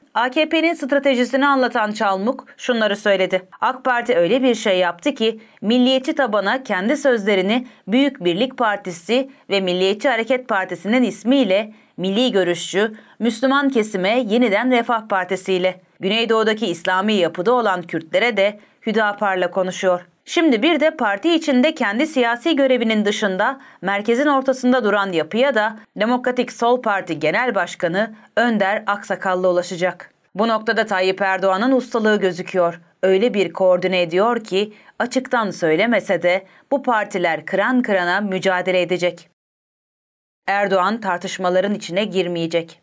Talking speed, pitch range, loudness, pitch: 120 wpm, 185-250 Hz, -19 LUFS, 210 Hz